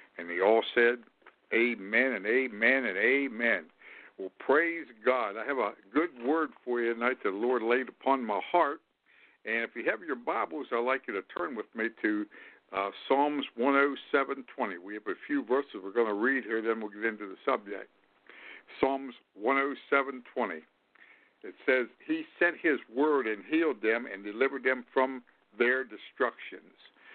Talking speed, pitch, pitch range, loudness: 170 wpm, 135 Hz, 120-160 Hz, -30 LUFS